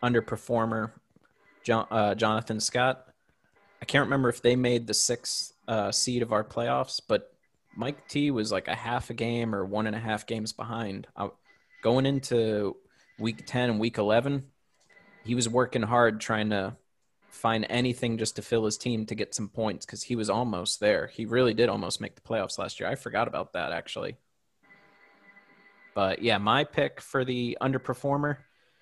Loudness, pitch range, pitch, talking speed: -28 LUFS, 110-125 Hz, 115 Hz, 175 wpm